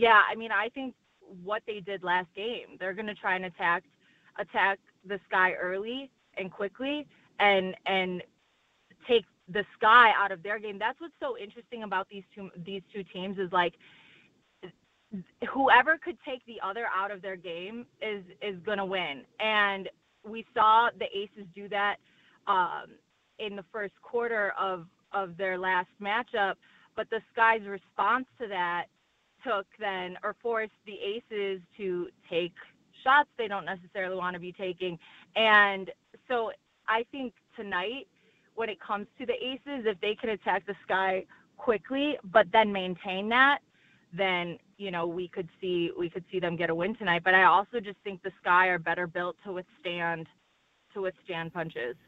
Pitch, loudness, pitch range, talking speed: 200 Hz, -29 LUFS, 185-220 Hz, 165 wpm